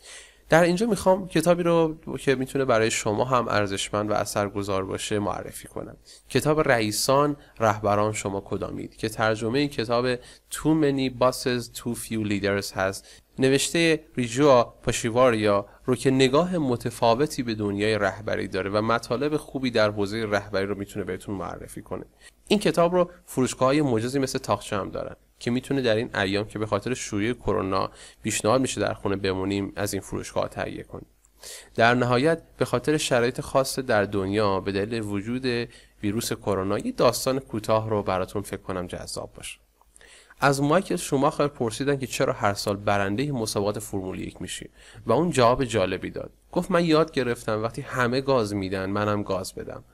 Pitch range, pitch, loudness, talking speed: 105-135 Hz, 115 Hz, -25 LUFS, 165 wpm